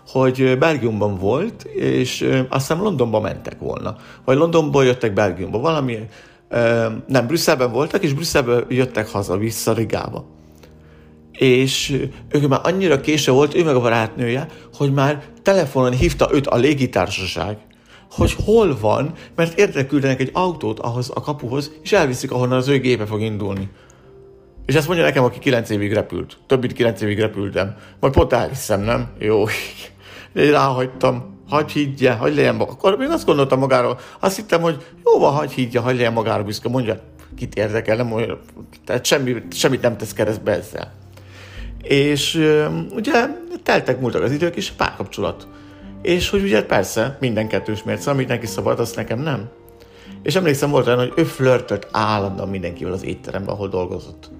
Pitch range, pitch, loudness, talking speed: 105-145 Hz, 125 Hz, -19 LUFS, 160 wpm